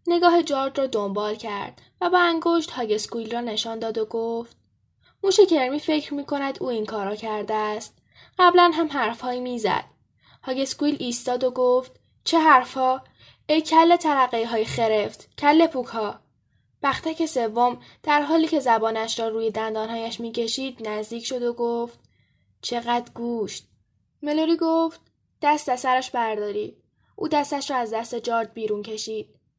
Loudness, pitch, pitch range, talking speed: -23 LUFS, 245 Hz, 225-295 Hz, 150 wpm